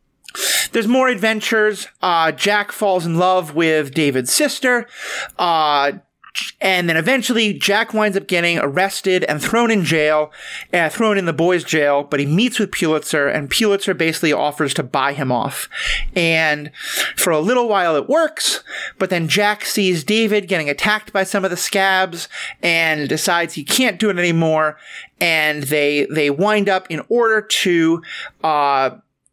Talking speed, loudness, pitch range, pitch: 160 wpm, -17 LUFS, 155-210 Hz, 180 Hz